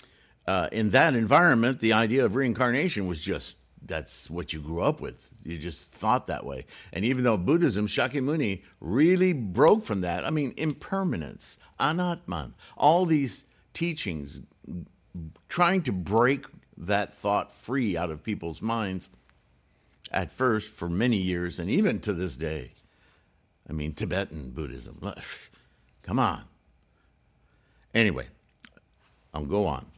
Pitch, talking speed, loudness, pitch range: 100 Hz, 135 wpm, -27 LUFS, 80-130 Hz